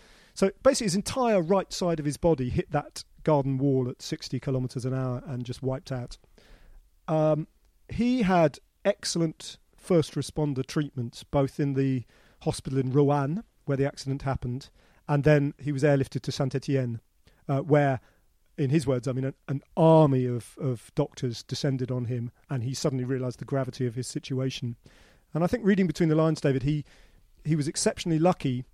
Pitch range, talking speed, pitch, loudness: 130-160 Hz, 175 wpm, 140 Hz, -27 LUFS